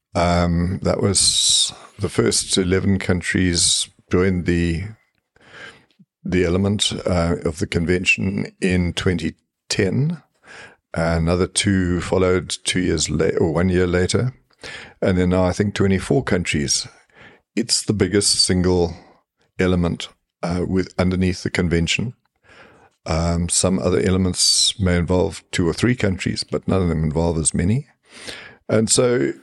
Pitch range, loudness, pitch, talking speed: 85-100 Hz, -19 LUFS, 90 Hz, 130 wpm